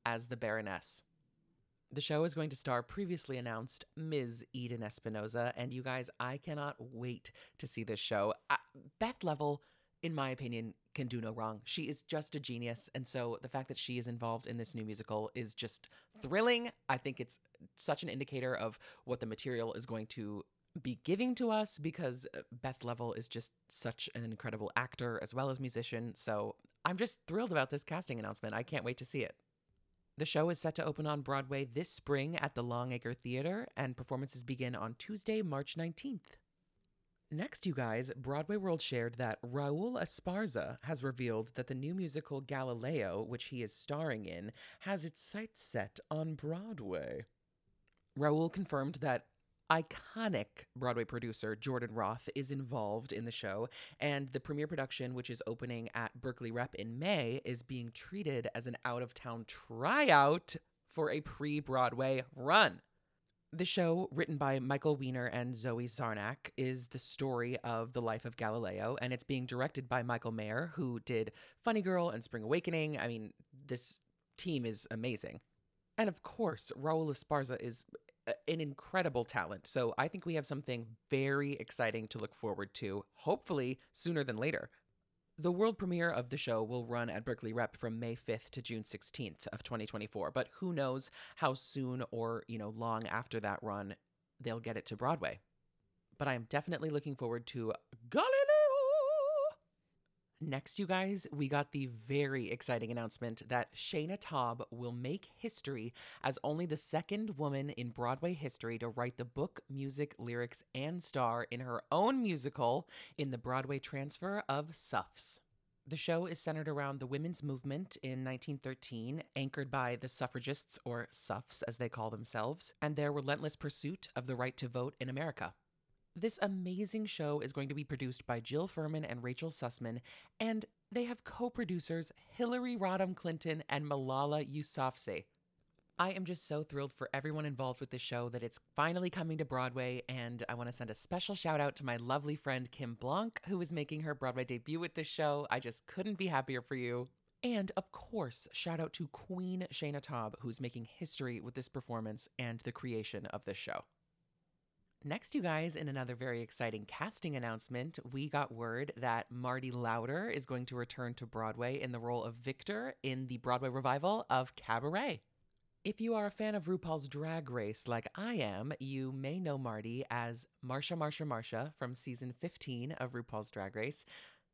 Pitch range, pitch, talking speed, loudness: 120-155 Hz, 130 Hz, 180 wpm, -39 LUFS